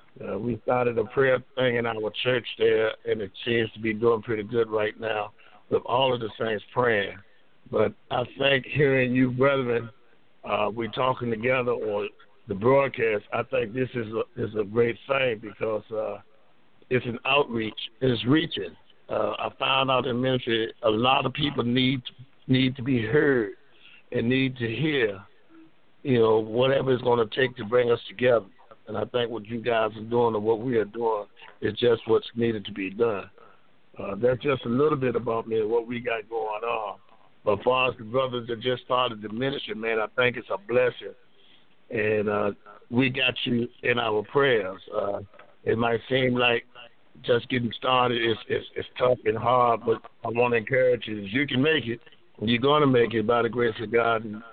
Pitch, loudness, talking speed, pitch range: 125 Hz, -25 LUFS, 200 wpm, 115-130 Hz